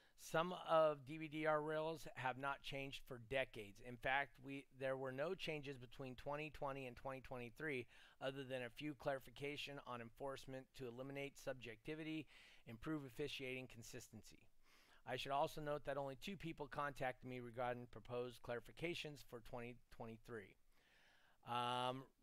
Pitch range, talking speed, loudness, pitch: 125-145 Hz, 130 wpm, -48 LUFS, 135 Hz